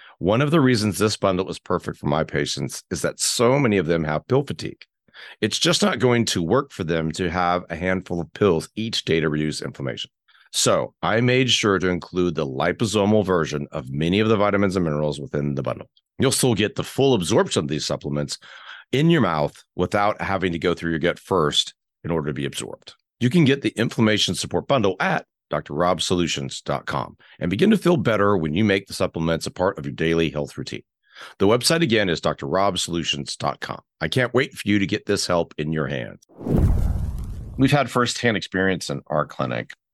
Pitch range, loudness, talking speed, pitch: 80-105 Hz, -22 LUFS, 200 wpm, 90 Hz